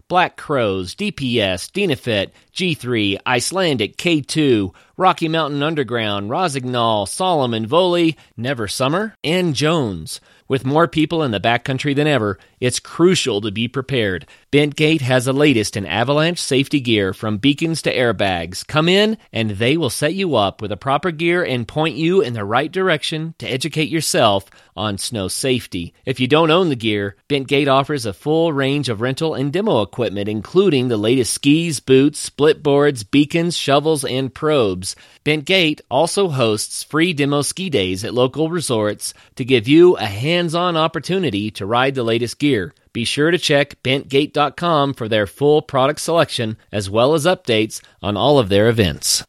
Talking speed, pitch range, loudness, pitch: 165 wpm, 115-160 Hz, -18 LUFS, 140 Hz